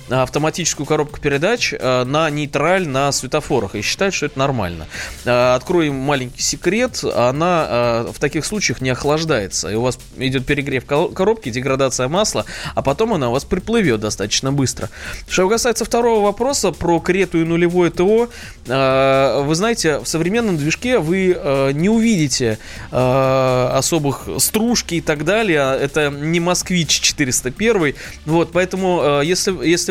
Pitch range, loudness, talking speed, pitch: 130-185 Hz, -17 LUFS, 135 wpm, 150 Hz